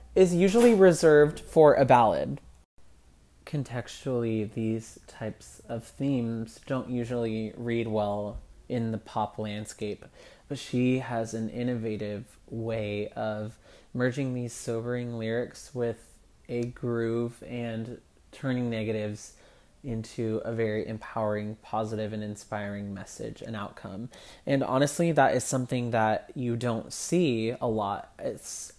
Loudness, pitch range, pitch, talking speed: -28 LUFS, 110-125 Hz, 115 Hz, 120 wpm